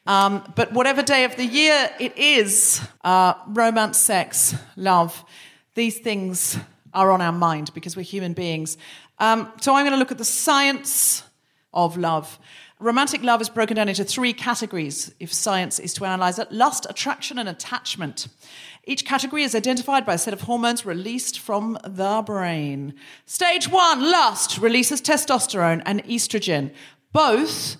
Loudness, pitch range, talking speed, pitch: -20 LUFS, 180-250 Hz, 160 wpm, 220 Hz